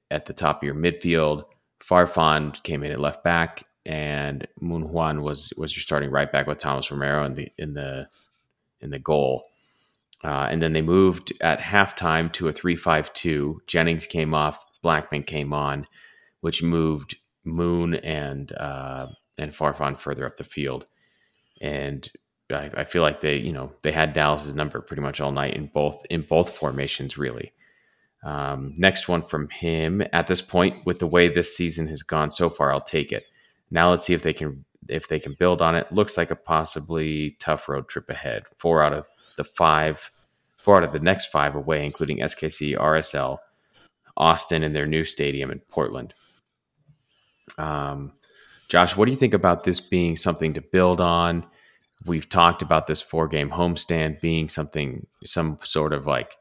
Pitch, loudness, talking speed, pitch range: 80 Hz, -23 LUFS, 180 wpm, 75-85 Hz